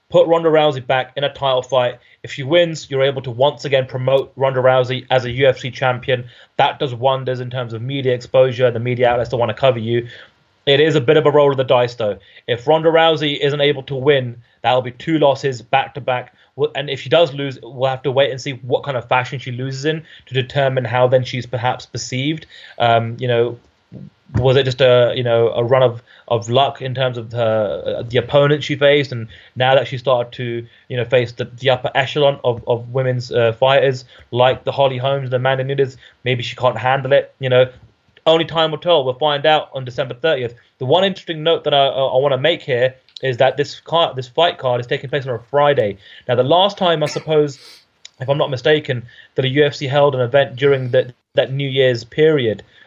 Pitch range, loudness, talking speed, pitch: 125-145 Hz, -17 LUFS, 225 wpm, 130 Hz